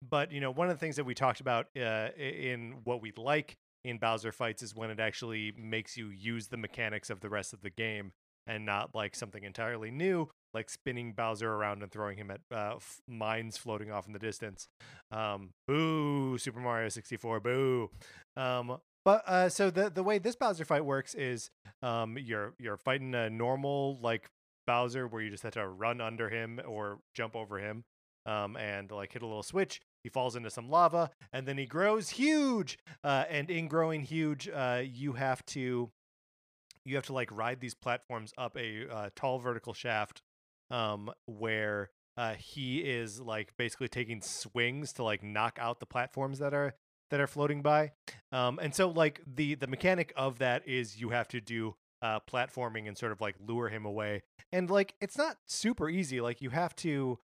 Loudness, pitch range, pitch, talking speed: -35 LUFS, 110-140 Hz, 120 Hz, 195 wpm